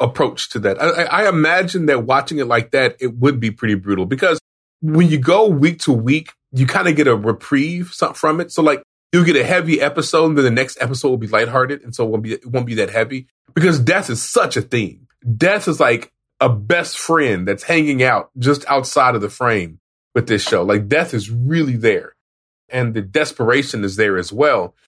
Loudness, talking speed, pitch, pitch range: -16 LUFS, 220 wpm, 135 Hz, 115-155 Hz